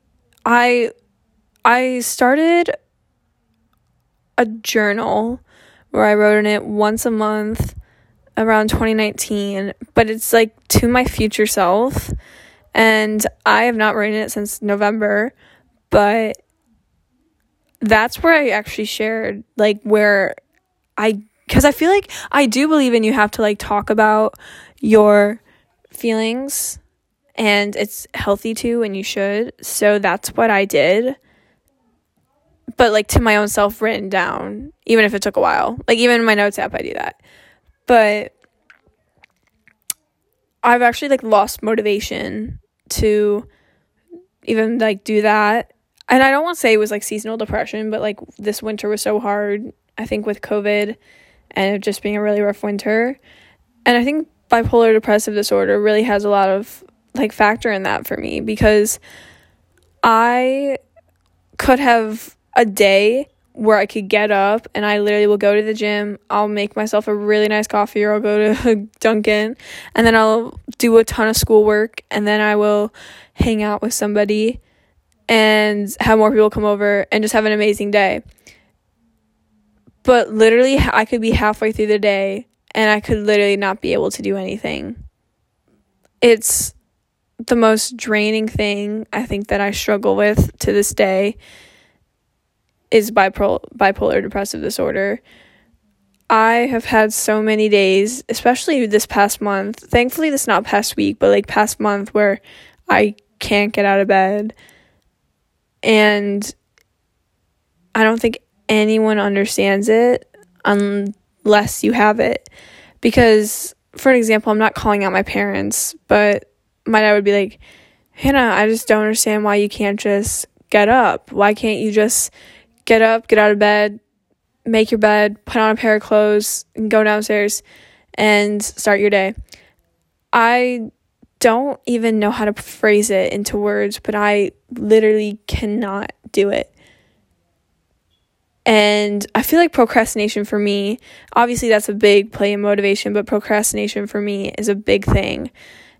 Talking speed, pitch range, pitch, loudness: 155 wpm, 205-225 Hz, 210 Hz, -16 LUFS